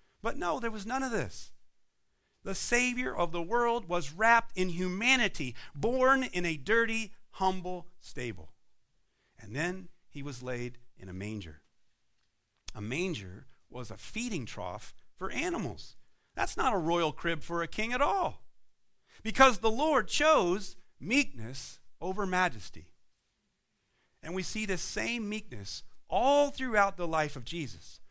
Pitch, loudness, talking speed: 180 Hz, -31 LUFS, 145 wpm